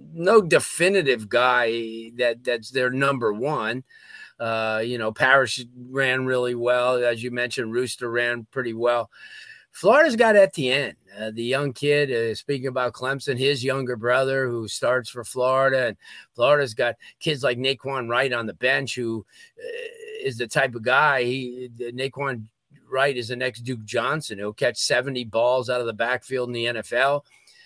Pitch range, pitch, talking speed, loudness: 120-135 Hz, 125 Hz, 165 wpm, -23 LUFS